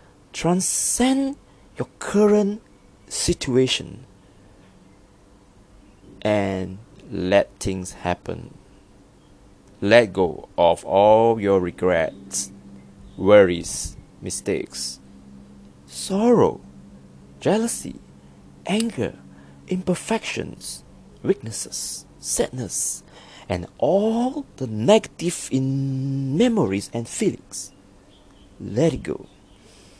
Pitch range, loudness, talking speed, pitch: 95-145 Hz, -22 LUFS, 65 wpm, 100 Hz